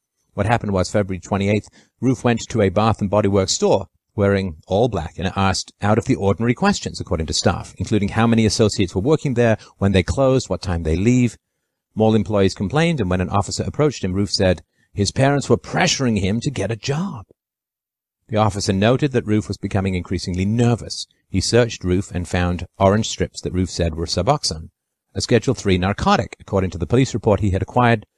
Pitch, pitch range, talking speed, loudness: 100 Hz, 95-120 Hz, 200 wpm, -19 LUFS